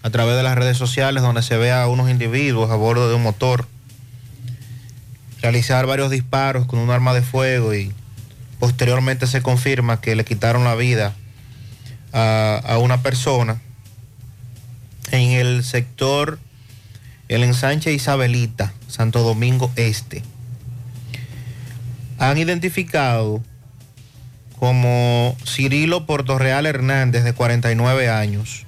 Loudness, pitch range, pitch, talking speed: -18 LUFS, 115-125 Hz, 125 Hz, 120 wpm